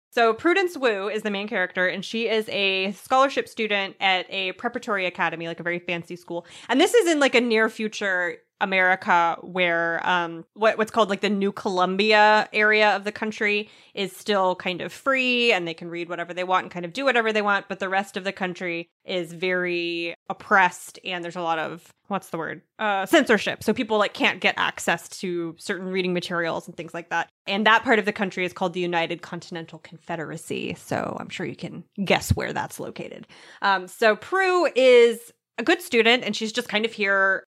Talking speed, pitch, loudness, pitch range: 210 wpm, 195 Hz, -23 LUFS, 175-220 Hz